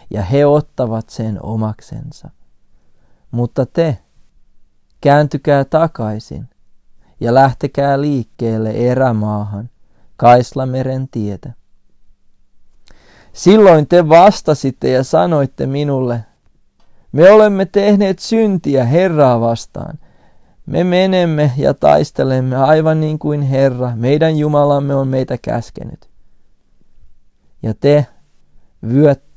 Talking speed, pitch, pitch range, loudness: 90 wpm, 130 Hz, 110-150 Hz, -13 LUFS